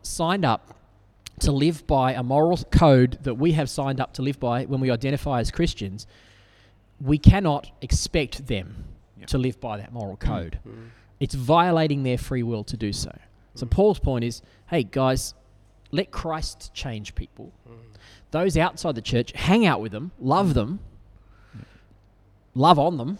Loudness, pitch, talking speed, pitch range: -23 LUFS, 125 Hz, 160 wpm, 105-145 Hz